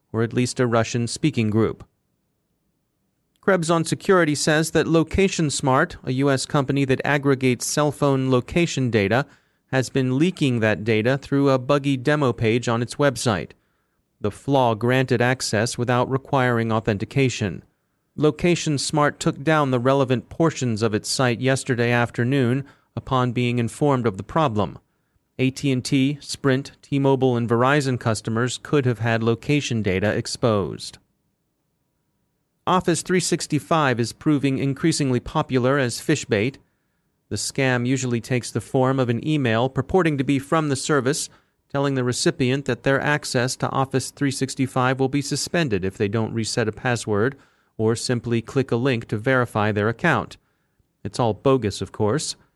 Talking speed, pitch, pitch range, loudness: 145 wpm, 130 Hz, 120-140 Hz, -22 LUFS